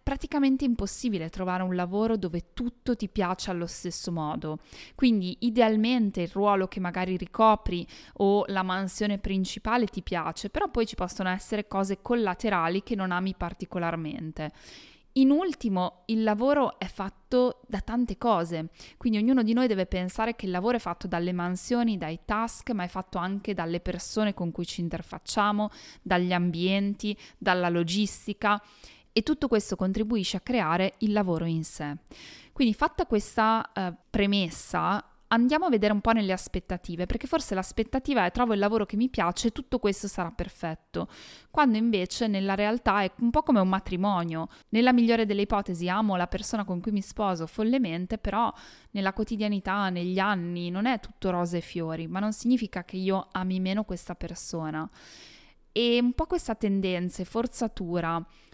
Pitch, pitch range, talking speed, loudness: 200 Hz, 180-225 Hz, 165 wpm, -28 LUFS